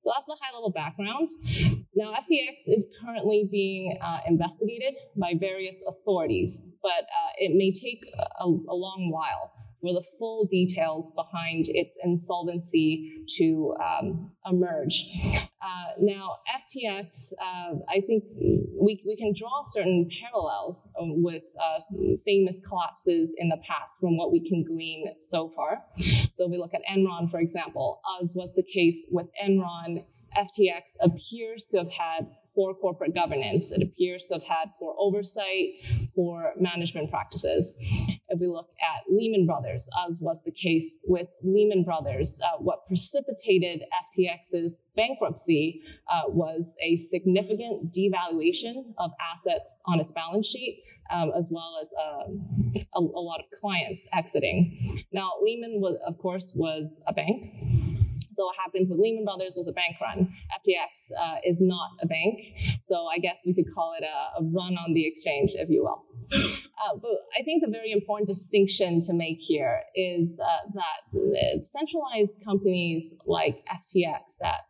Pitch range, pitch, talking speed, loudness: 170-210 Hz, 185 Hz, 155 wpm, -27 LUFS